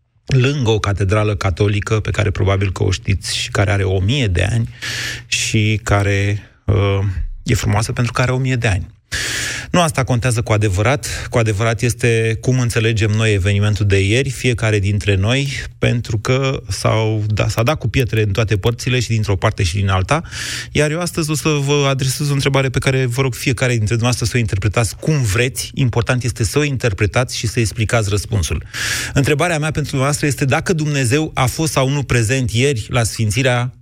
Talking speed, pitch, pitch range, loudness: 190 wpm, 120 Hz, 105-130 Hz, -17 LUFS